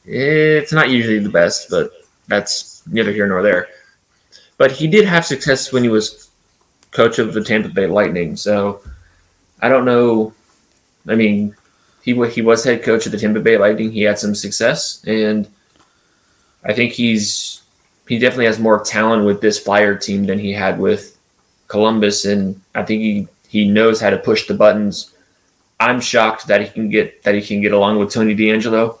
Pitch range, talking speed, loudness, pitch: 100-120 Hz, 180 wpm, -15 LUFS, 110 Hz